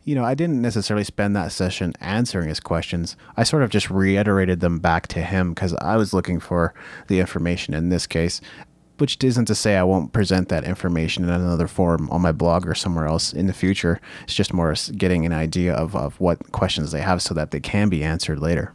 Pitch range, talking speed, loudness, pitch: 85-100 Hz, 225 wpm, -21 LUFS, 90 Hz